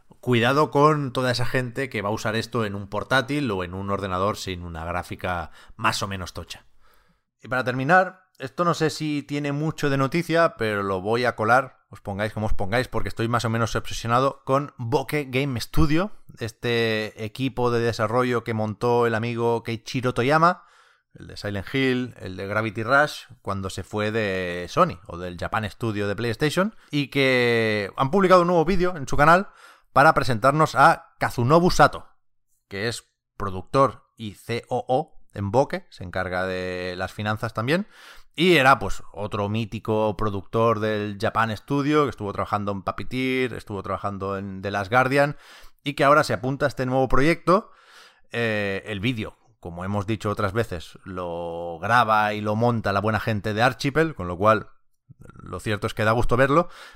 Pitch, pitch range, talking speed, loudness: 115 Hz, 105-135 Hz, 180 wpm, -23 LUFS